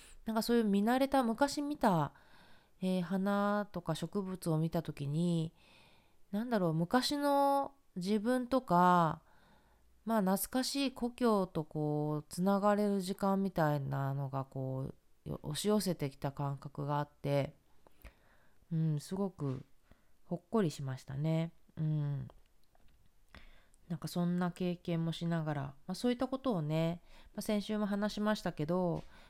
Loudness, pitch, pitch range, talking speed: -35 LUFS, 175 Hz, 150-210 Hz, 260 characters per minute